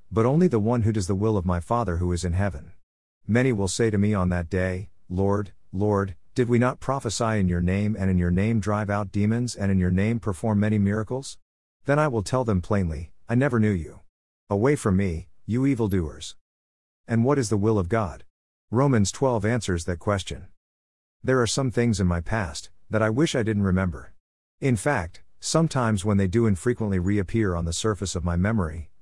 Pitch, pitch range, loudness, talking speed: 100 Hz, 90-115 Hz, -24 LUFS, 205 wpm